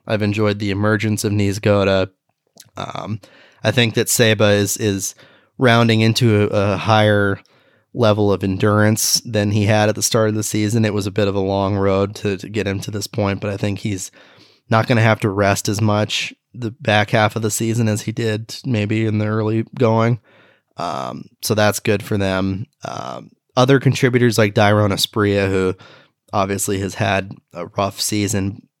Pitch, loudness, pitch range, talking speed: 105 Hz, -18 LUFS, 100-110 Hz, 190 wpm